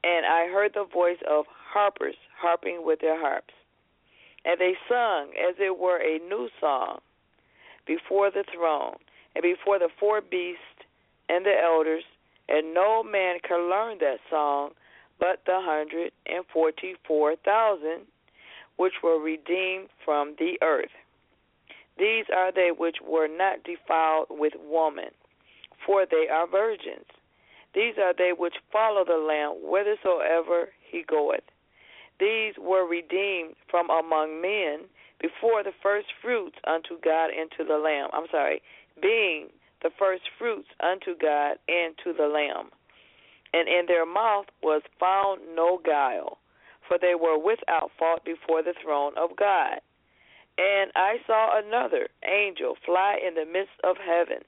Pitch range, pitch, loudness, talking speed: 160-205 Hz, 180 Hz, -26 LUFS, 145 wpm